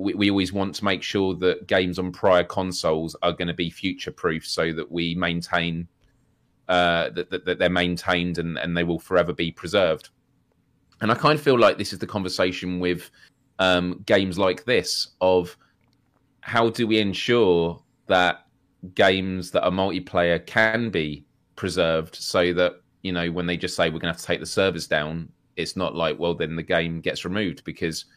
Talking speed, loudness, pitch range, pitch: 185 wpm, -23 LUFS, 85-95 Hz, 90 Hz